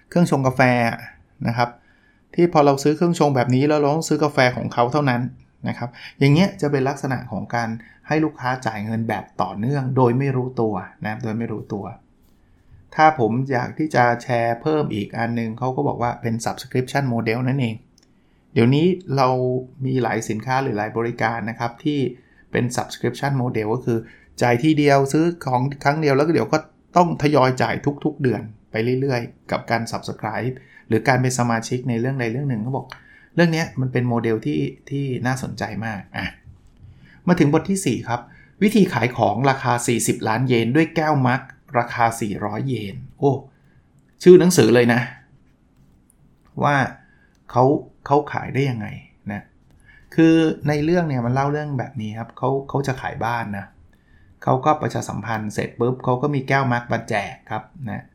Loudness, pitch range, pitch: -21 LUFS, 115-140 Hz, 125 Hz